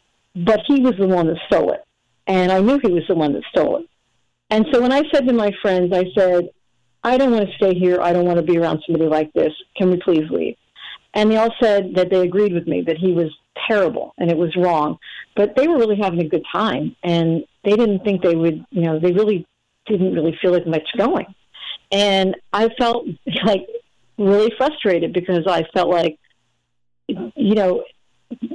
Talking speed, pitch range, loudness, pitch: 210 wpm, 170-220 Hz, -18 LUFS, 185 Hz